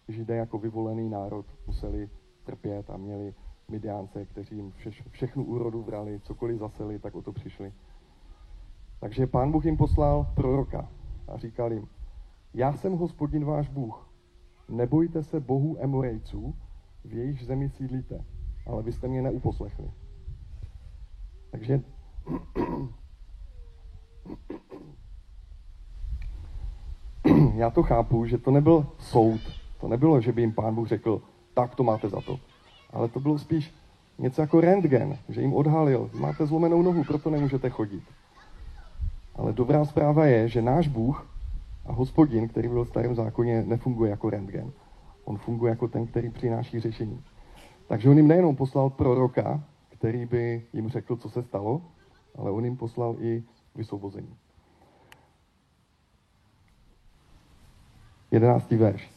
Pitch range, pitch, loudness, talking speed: 100-130 Hz, 115 Hz, -26 LUFS, 130 wpm